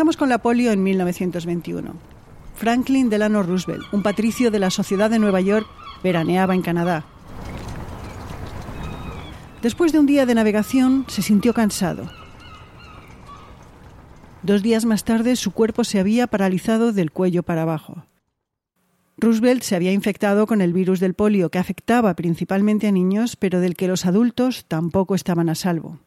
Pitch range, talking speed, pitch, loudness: 180-225 Hz, 150 wpm, 200 Hz, -19 LUFS